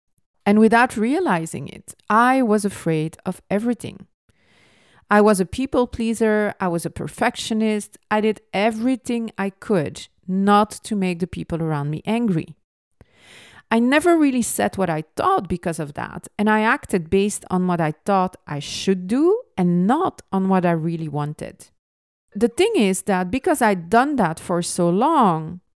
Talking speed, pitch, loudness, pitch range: 165 wpm, 195 Hz, -20 LUFS, 175-225 Hz